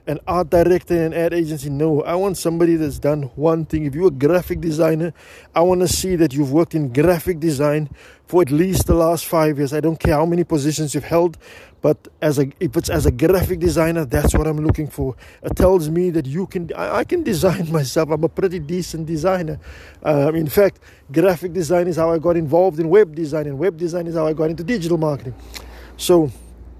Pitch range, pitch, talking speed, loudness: 150-175 Hz, 165 Hz, 220 wpm, -18 LUFS